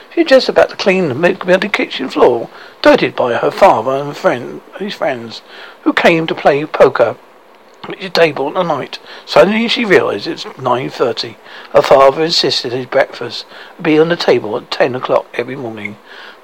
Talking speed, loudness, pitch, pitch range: 175 wpm, -13 LUFS, 170 Hz, 140-200 Hz